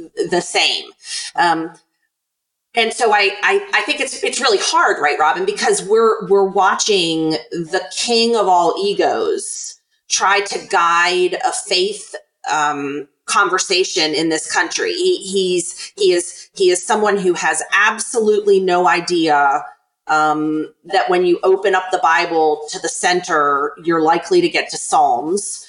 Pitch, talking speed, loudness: 220 Hz, 145 wpm, -16 LUFS